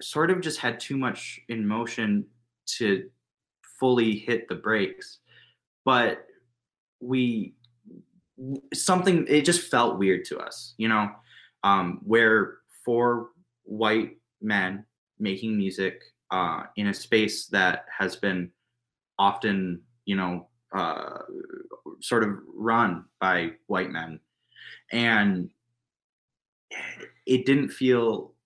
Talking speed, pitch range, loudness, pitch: 110 wpm, 100-130 Hz, -26 LUFS, 115 Hz